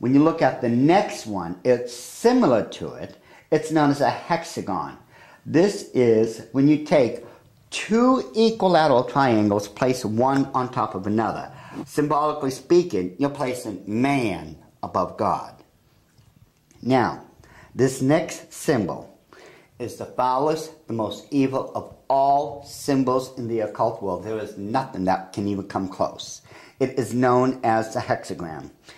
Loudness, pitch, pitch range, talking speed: -22 LUFS, 130 Hz, 110-145 Hz, 140 wpm